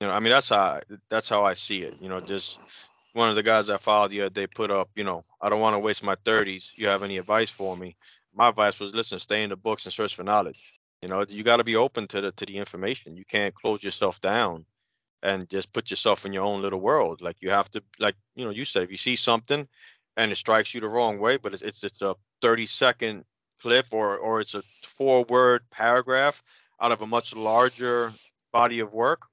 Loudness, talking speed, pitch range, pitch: -25 LUFS, 250 wpm, 100-115 Hz, 105 Hz